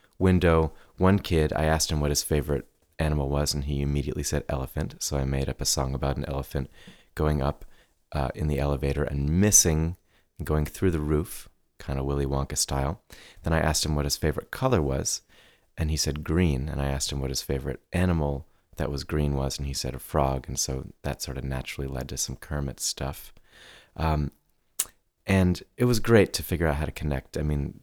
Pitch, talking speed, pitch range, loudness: 75 Hz, 205 wpm, 70-80 Hz, -27 LUFS